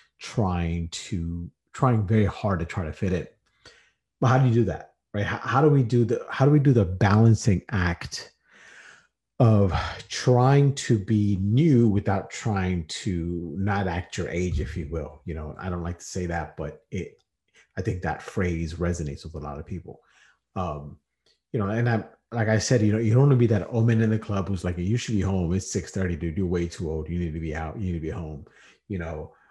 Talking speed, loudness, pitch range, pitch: 225 wpm, -25 LUFS, 85-110 Hz, 95 Hz